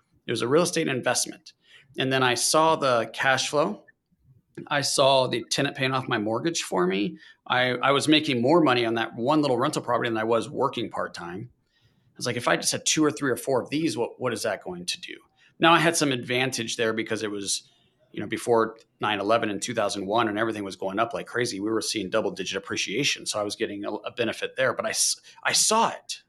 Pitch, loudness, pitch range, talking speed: 130 Hz, -25 LUFS, 115-150 Hz, 235 wpm